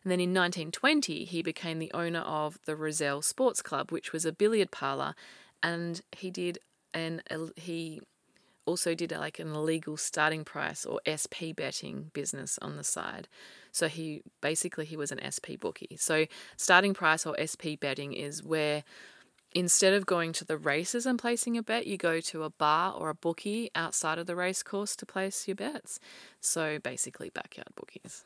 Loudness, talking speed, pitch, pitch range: -31 LUFS, 180 wpm, 165 Hz, 155-185 Hz